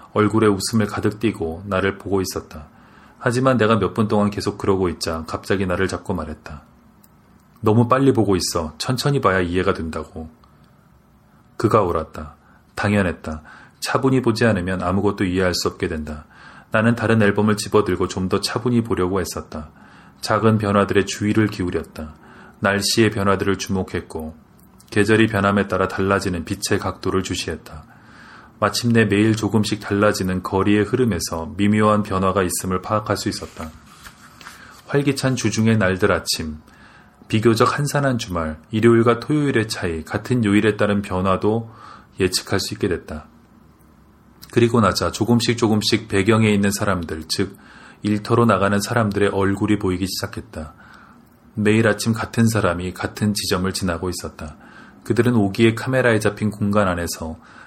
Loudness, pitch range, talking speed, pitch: -20 LUFS, 90-110 Hz, 330 characters per minute, 100 Hz